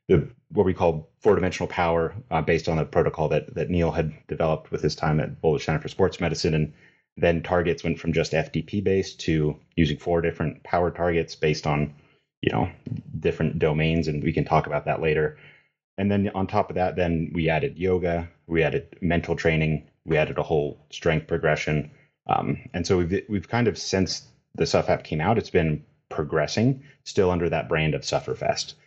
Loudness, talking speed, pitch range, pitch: -25 LUFS, 195 wpm, 80-90 Hz, 85 Hz